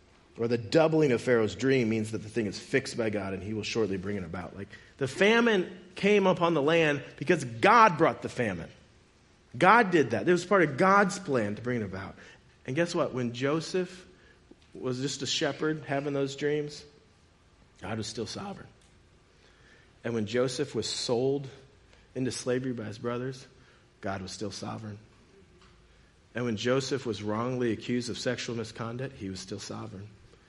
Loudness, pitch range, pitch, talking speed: -28 LUFS, 105-140 Hz, 120 Hz, 175 wpm